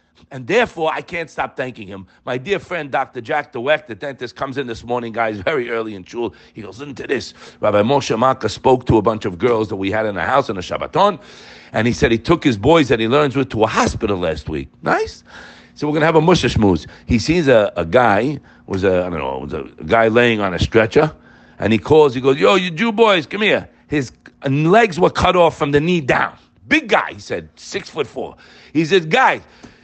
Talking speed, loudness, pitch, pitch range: 240 wpm, -17 LUFS, 130 Hz, 110-155 Hz